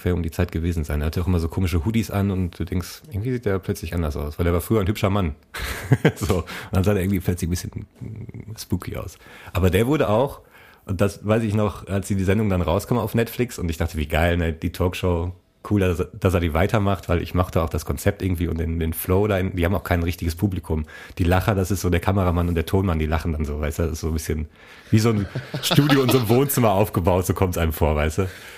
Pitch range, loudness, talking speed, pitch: 85-105 Hz, -22 LUFS, 265 wpm, 95 Hz